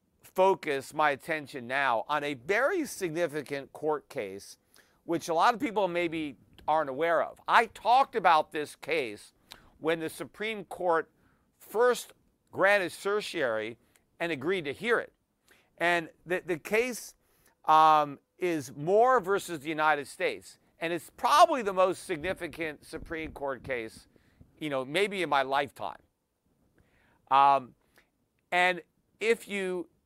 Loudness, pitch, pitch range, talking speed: -29 LUFS, 165 Hz, 140-190 Hz, 130 wpm